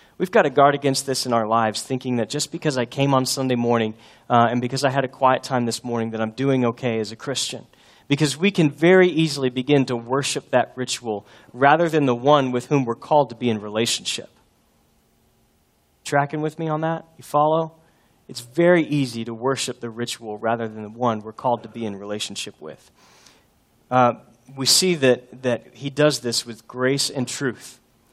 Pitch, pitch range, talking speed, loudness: 125 Hz, 115-145 Hz, 200 wpm, -21 LUFS